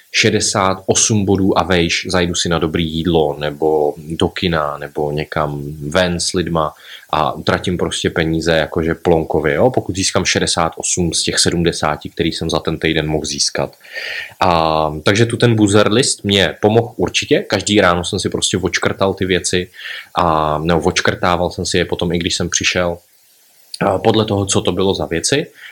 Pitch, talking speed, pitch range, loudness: 90 Hz, 170 wpm, 80-100 Hz, -16 LUFS